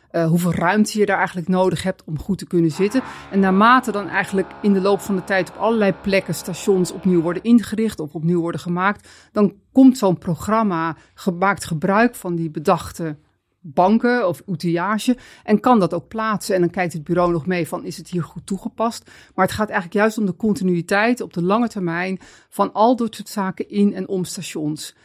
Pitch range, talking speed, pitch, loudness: 175-210 Hz, 205 wpm, 190 Hz, -20 LUFS